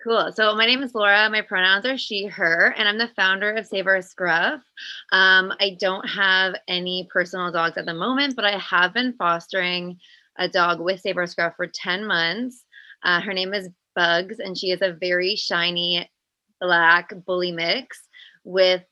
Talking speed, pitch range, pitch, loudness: 180 wpm, 180-210 Hz, 190 Hz, -21 LUFS